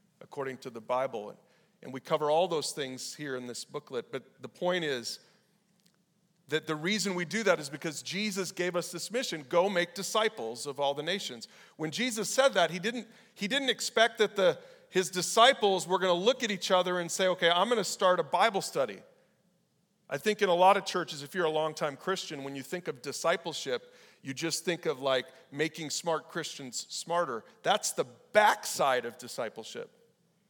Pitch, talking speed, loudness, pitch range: 180 Hz, 190 wpm, -30 LUFS, 155-205 Hz